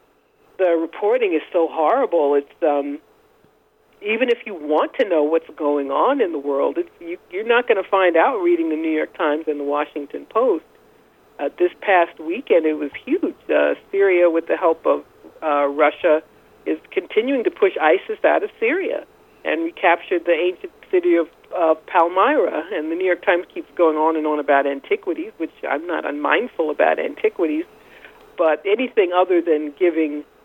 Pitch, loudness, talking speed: 180 Hz, -20 LUFS, 180 wpm